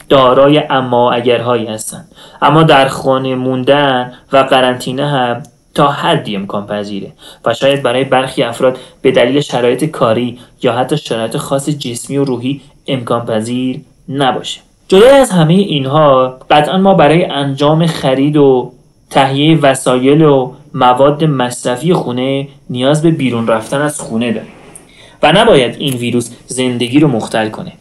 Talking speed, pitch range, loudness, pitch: 140 wpm, 125-145 Hz, -11 LUFS, 135 Hz